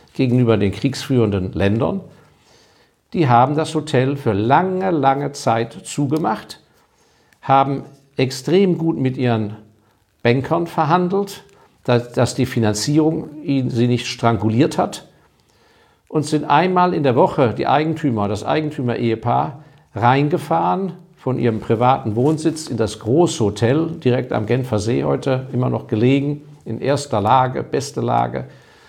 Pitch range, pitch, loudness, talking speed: 115-155 Hz, 135 Hz, -18 LUFS, 125 wpm